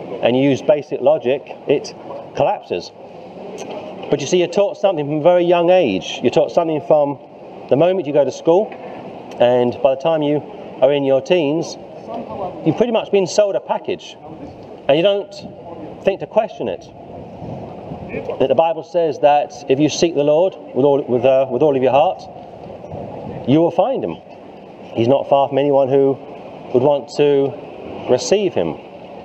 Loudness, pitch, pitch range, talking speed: -17 LUFS, 150 Hz, 140-180 Hz, 175 wpm